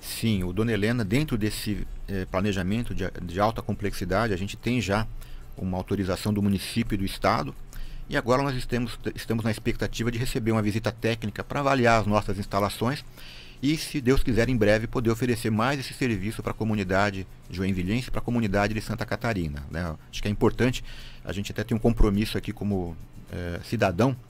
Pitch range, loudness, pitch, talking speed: 100-120 Hz, -27 LUFS, 110 Hz, 190 wpm